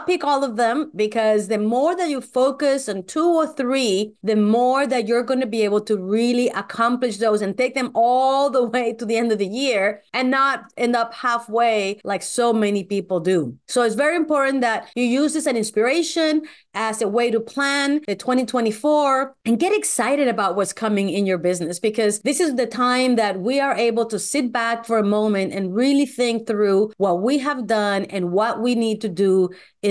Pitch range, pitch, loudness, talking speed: 210-265 Hz, 235 Hz, -20 LUFS, 210 wpm